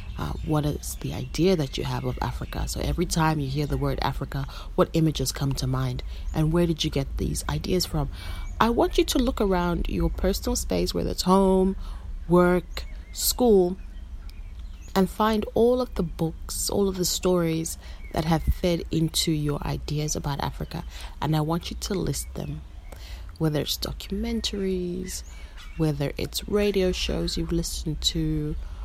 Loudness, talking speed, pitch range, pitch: -26 LUFS, 165 wpm, 130-185 Hz, 160 Hz